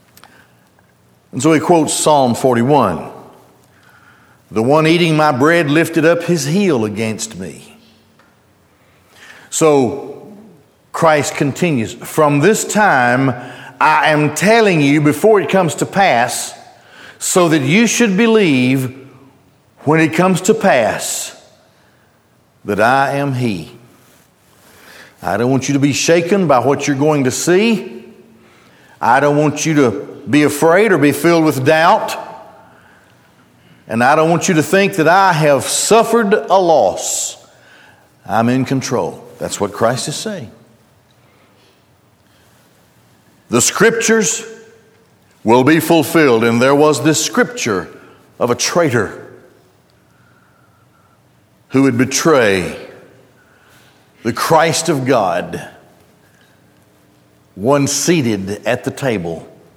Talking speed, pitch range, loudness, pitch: 115 wpm, 130-175 Hz, -13 LUFS, 150 Hz